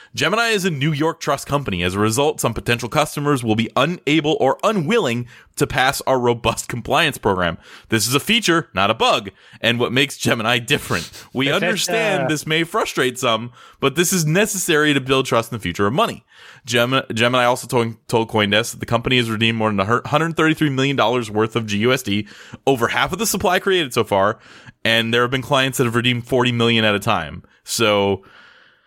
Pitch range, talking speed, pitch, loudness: 115-150 Hz, 195 wpm, 125 Hz, -18 LUFS